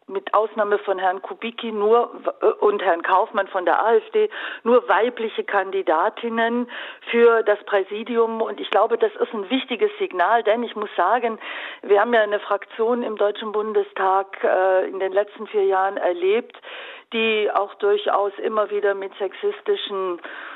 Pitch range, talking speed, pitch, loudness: 195-235 Hz, 150 wpm, 215 Hz, -21 LUFS